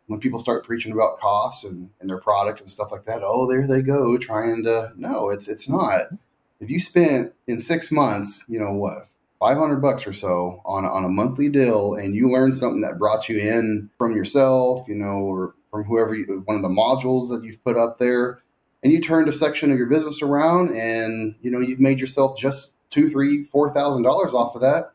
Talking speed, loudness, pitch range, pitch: 220 wpm, -21 LUFS, 105-135 Hz, 120 Hz